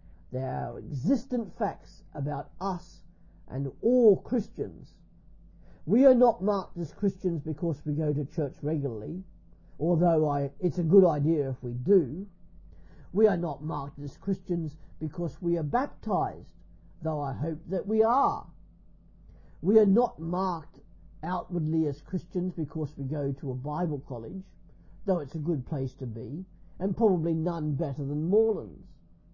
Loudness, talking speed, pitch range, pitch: -29 LUFS, 150 wpm, 145-185 Hz, 165 Hz